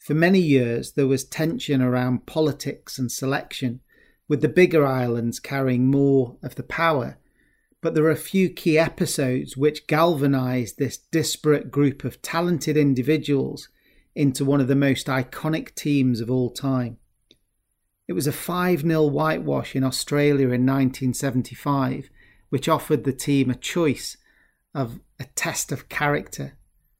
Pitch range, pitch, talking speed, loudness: 130-155 Hz, 140 Hz, 145 wpm, -23 LUFS